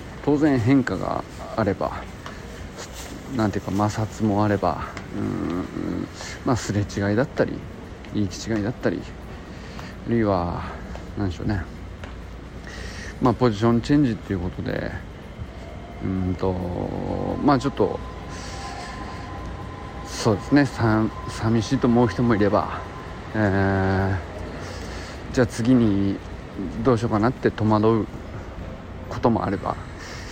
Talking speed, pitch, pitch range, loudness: 235 characters per minute, 100 Hz, 90-115 Hz, -24 LUFS